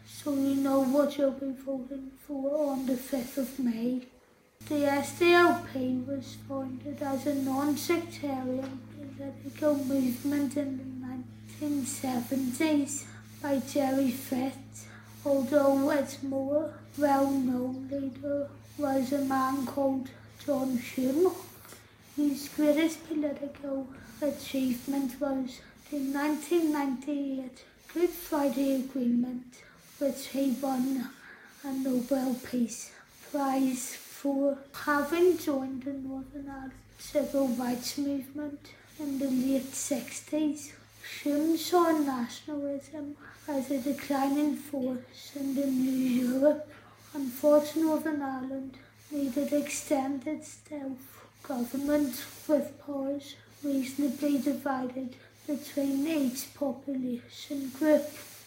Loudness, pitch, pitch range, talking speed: -31 LUFS, 275 Hz, 265-290 Hz, 100 wpm